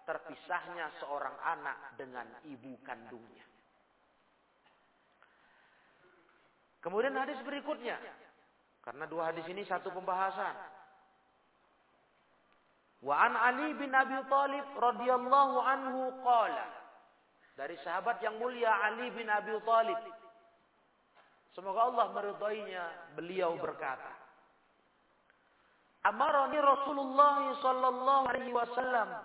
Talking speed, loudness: 85 wpm, -33 LUFS